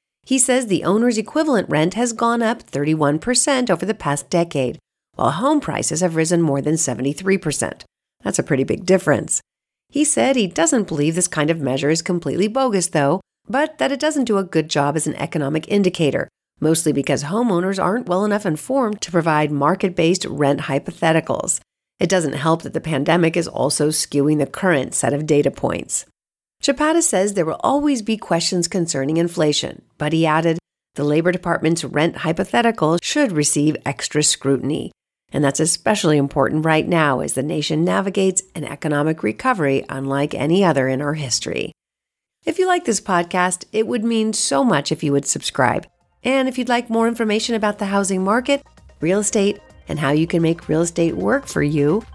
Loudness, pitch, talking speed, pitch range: -19 LUFS, 170 Hz, 180 wpm, 150-210 Hz